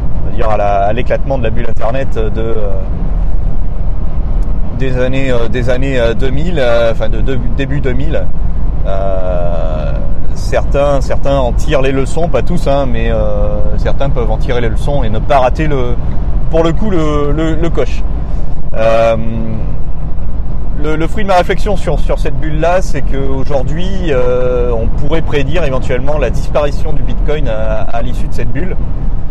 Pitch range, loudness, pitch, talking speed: 105-140 Hz, -15 LUFS, 120 Hz, 165 wpm